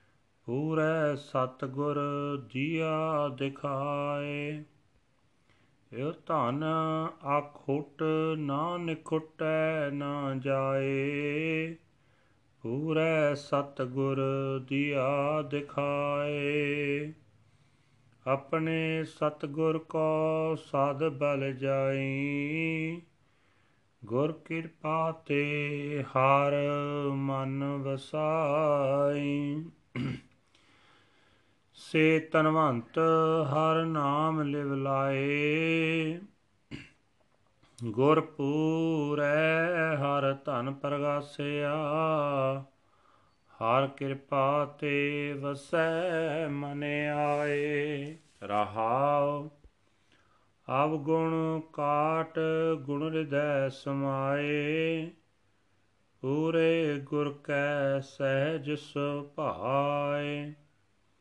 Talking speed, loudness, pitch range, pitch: 55 wpm, -30 LUFS, 135-155 Hz, 145 Hz